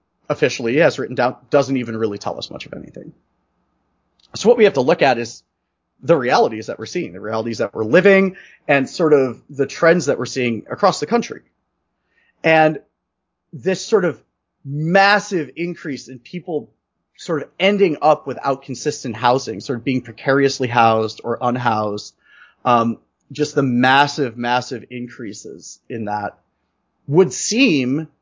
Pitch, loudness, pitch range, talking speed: 135 Hz, -18 LUFS, 120-160 Hz, 155 wpm